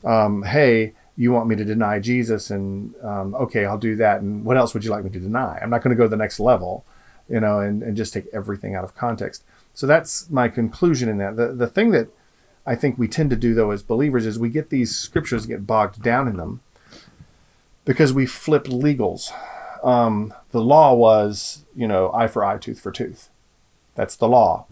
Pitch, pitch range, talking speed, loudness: 115 Hz, 105-125 Hz, 220 wpm, -20 LUFS